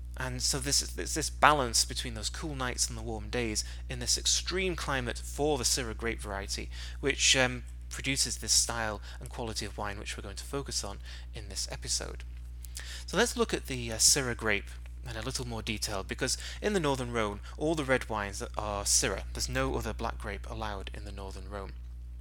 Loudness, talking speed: -30 LUFS, 205 wpm